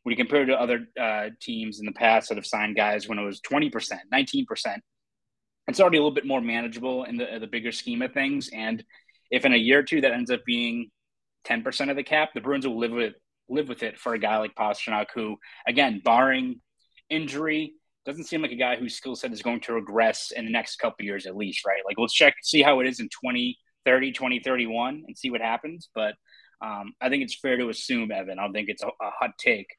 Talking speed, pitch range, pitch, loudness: 250 wpm, 115-155 Hz, 130 Hz, -25 LUFS